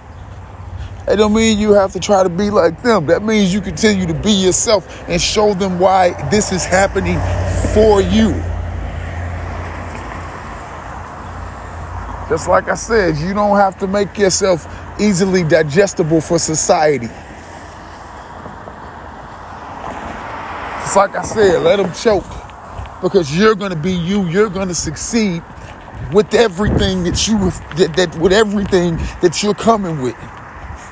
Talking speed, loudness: 130 wpm, -14 LUFS